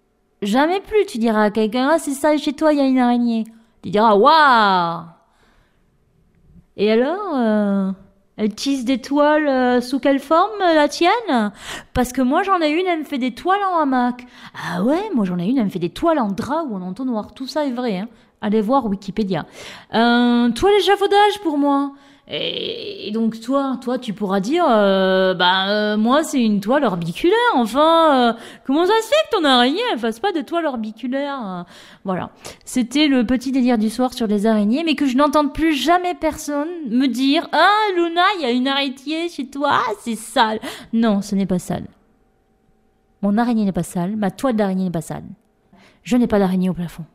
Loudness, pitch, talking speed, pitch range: -18 LUFS, 250 Hz, 200 wpm, 215-300 Hz